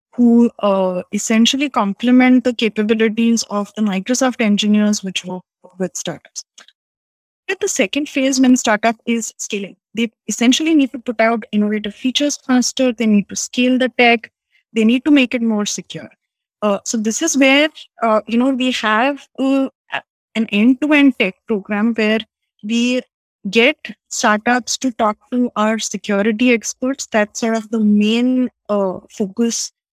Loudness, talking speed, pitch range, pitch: -16 LUFS, 150 wpm, 210-255 Hz, 230 Hz